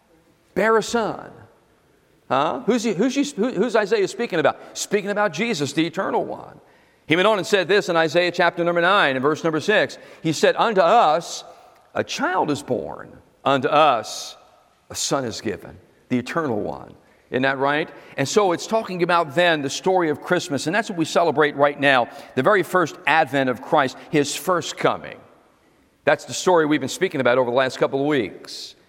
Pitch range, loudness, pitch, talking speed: 140-200 Hz, -20 LUFS, 165 Hz, 190 wpm